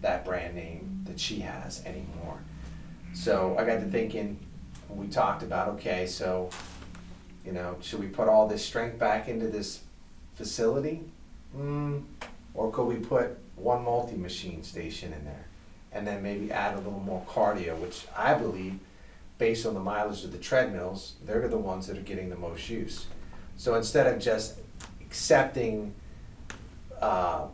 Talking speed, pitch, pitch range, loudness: 160 wpm, 100 Hz, 90-110 Hz, -30 LUFS